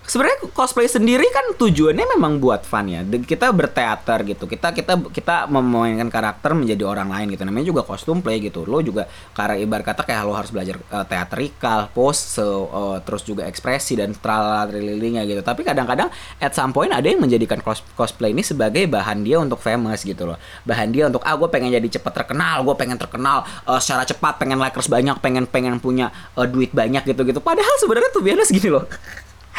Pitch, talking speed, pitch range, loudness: 120 Hz, 190 wpm, 105-150 Hz, -19 LUFS